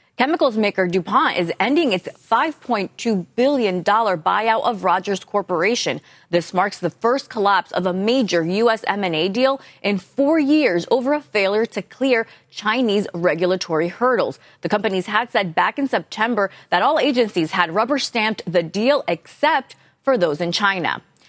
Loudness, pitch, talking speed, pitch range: -19 LUFS, 210 Hz, 150 wpm, 180-245 Hz